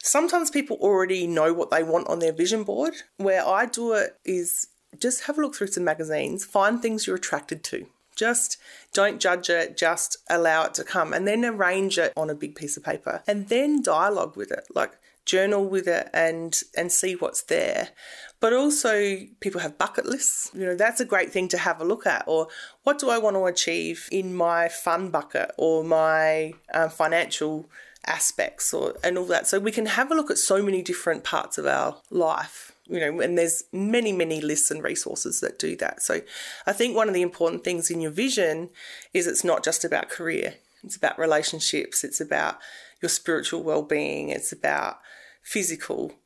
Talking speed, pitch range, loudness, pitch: 195 wpm, 165-225 Hz, -24 LUFS, 185 Hz